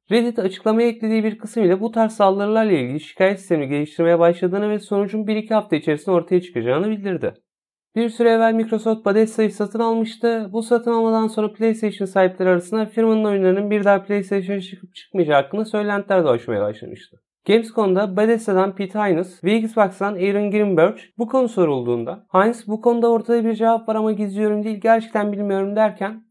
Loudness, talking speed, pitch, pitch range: -19 LUFS, 160 wpm, 210 Hz, 190-220 Hz